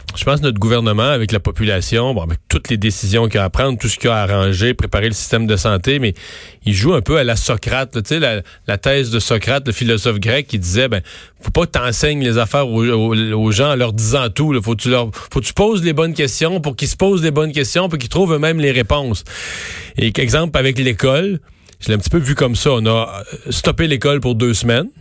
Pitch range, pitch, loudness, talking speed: 110-140 Hz, 120 Hz, -16 LUFS, 245 wpm